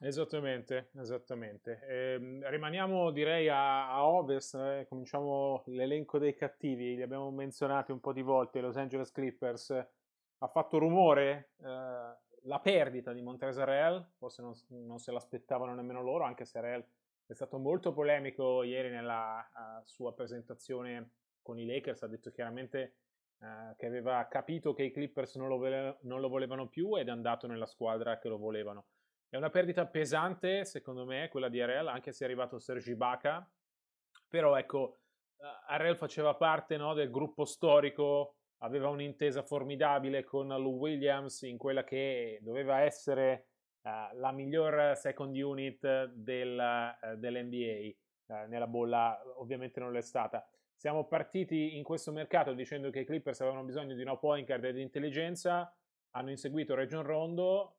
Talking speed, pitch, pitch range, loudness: 155 wpm, 135 Hz, 125-145 Hz, -36 LUFS